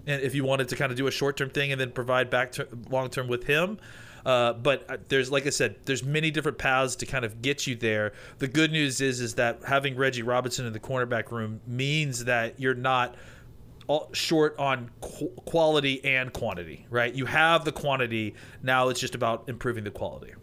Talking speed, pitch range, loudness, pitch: 210 wpm, 120-140 Hz, -27 LUFS, 130 Hz